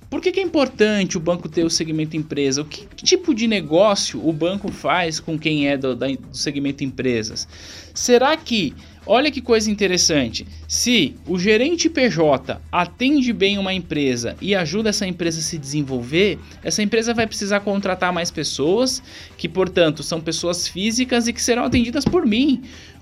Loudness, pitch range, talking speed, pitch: -19 LUFS, 155-235 Hz, 170 wpm, 185 Hz